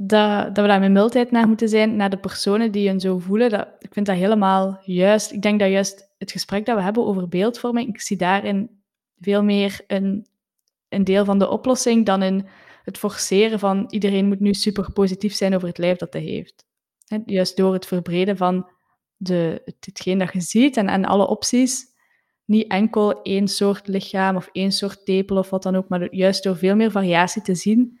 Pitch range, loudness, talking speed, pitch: 190-210 Hz, -20 LUFS, 205 wpm, 200 Hz